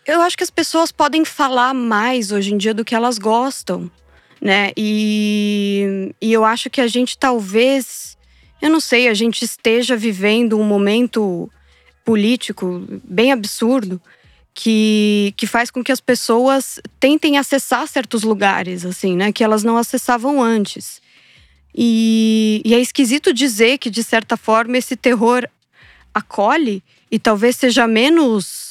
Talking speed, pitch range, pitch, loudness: 145 wpm, 210-255 Hz, 230 Hz, -16 LUFS